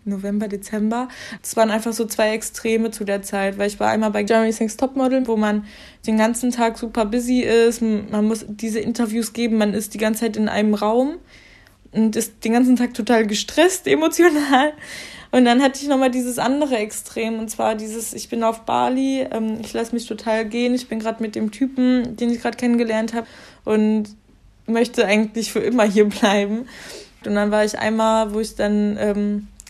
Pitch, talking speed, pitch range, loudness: 225 Hz, 195 wpm, 215-240 Hz, -20 LUFS